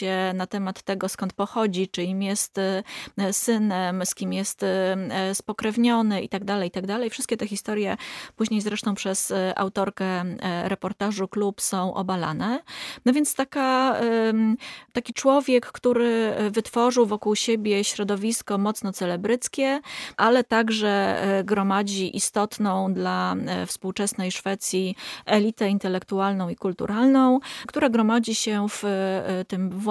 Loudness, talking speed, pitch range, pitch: -24 LUFS, 120 wpm, 190-230 Hz, 205 Hz